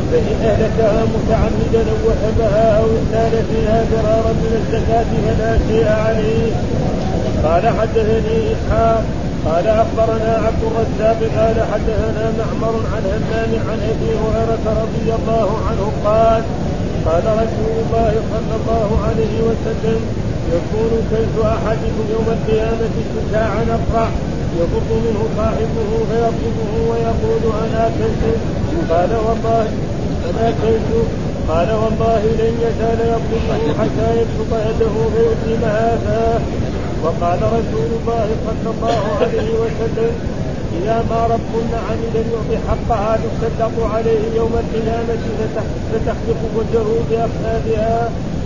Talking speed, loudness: 105 wpm, -17 LUFS